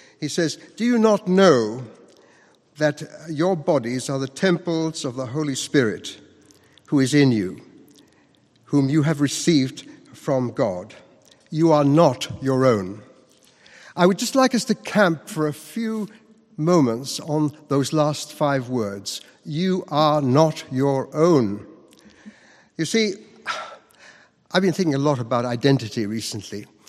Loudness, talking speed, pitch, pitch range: -21 LUFS, 140 wpm, 150 Hz, 130-170 Hz